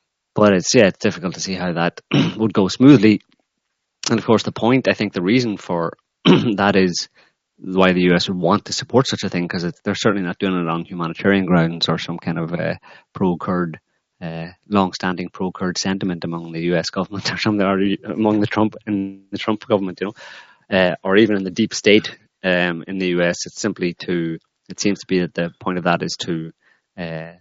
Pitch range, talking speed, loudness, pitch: 85-105 Hz, 210 wpm, -19 LUFS, 95 Hz